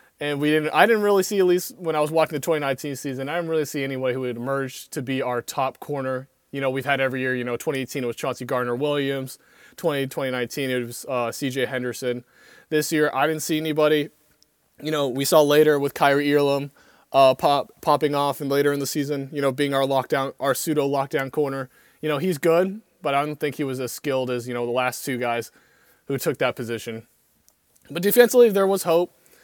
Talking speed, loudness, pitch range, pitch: 220 wpm, -23 LUFS, 130-150 Hz, 140 Hz